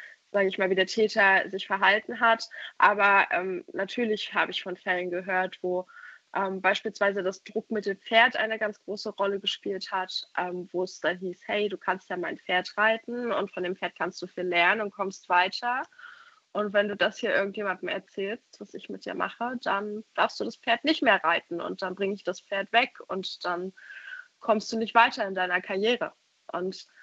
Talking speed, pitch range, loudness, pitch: 200 wpm, 185-220 Hz, -27 LUFS, 195 Hz